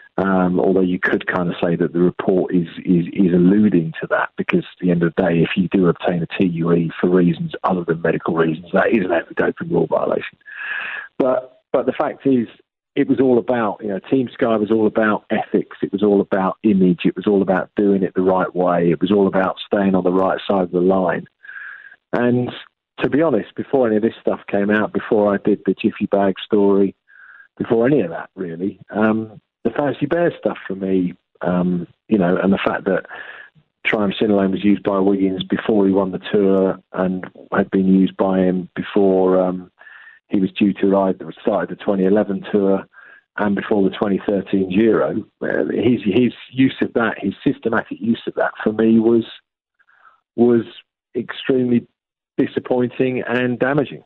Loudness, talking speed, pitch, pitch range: -18 LUFS, 195 wpm, 100 Hz, 95-110 Hz